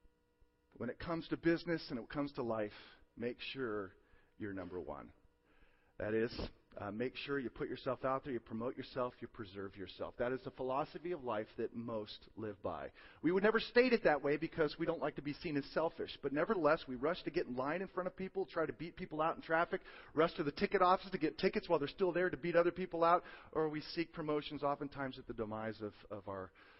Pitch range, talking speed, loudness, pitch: 120-170 Hz, 235 wpm, -39 LUFS, 145 Hz